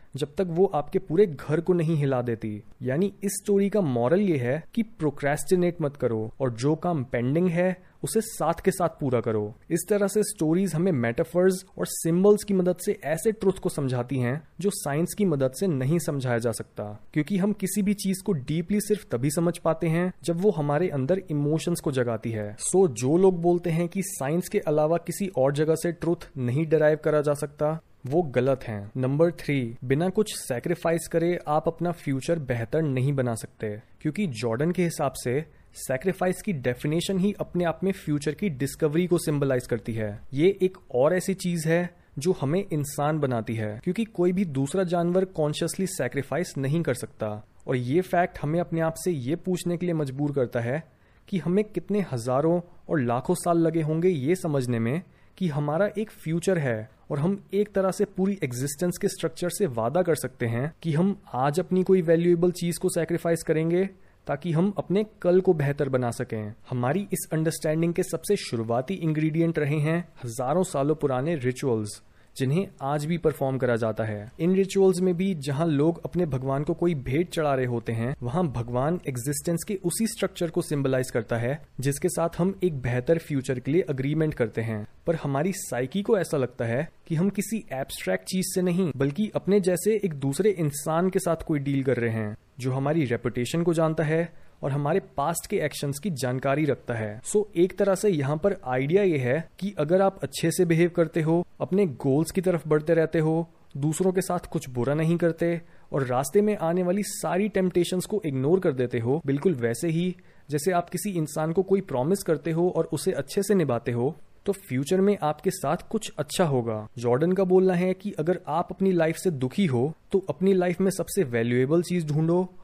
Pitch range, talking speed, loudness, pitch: 135-185 Hz, 200 wpm, -26 LUFS, 165 Hz